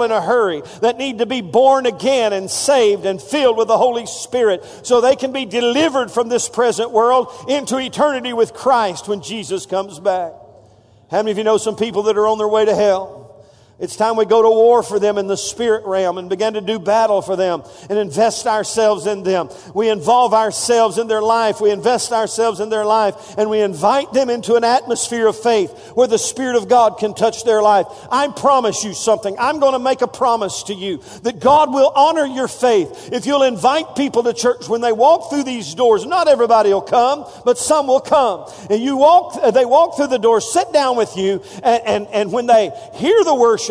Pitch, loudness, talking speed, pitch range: 225 Hz, -16 LUFS, 220 wpm, 210-255 Hz